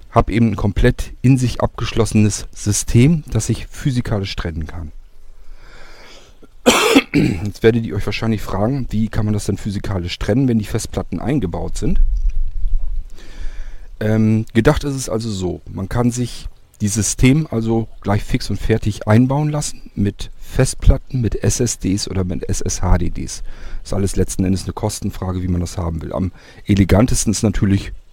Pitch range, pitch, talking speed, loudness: 90-115 Hz, 105 Hz, 155 wpm, -18 LUFS